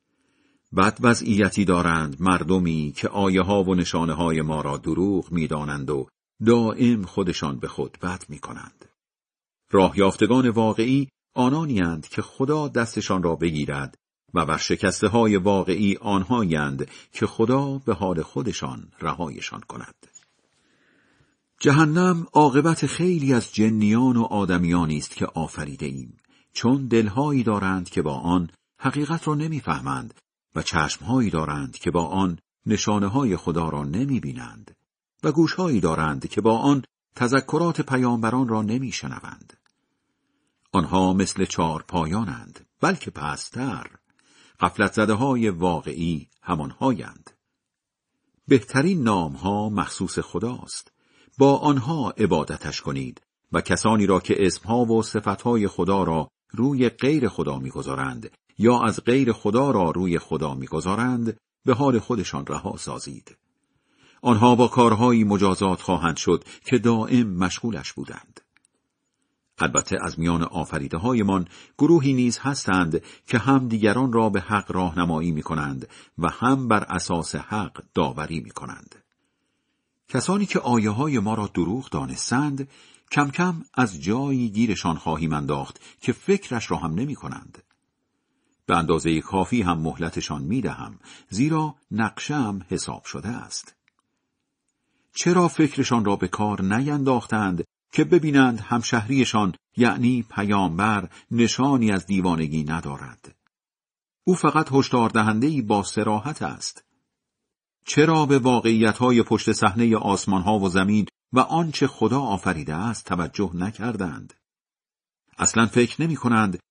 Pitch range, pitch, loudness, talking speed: 90-125 Hz, 105 Hz, -23 LUFS, 125 wpm